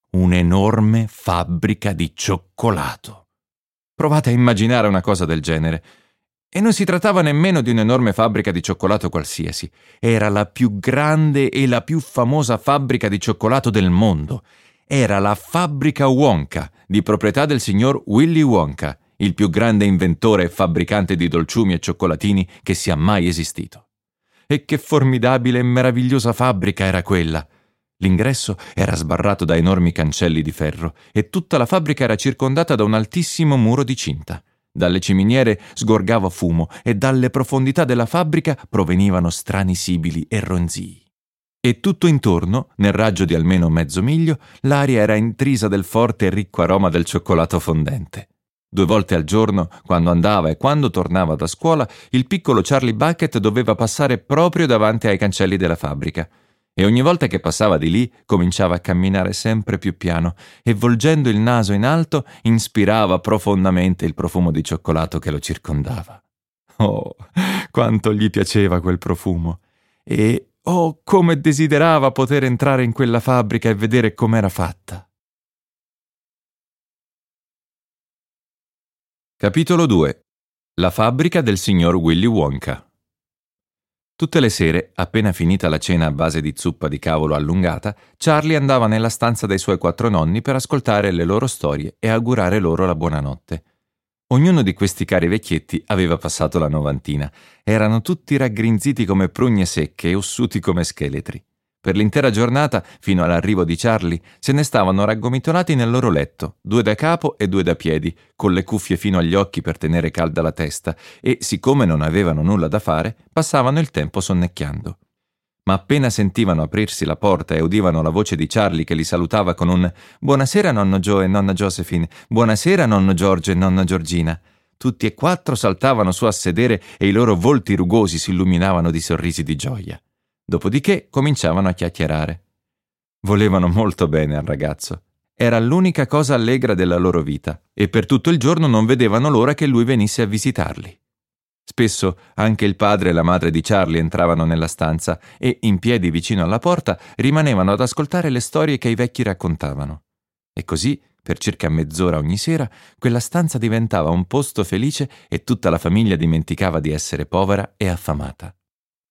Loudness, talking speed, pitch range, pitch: -18 LUFS, 160 wpm, 85-125 Hz, 105 Hz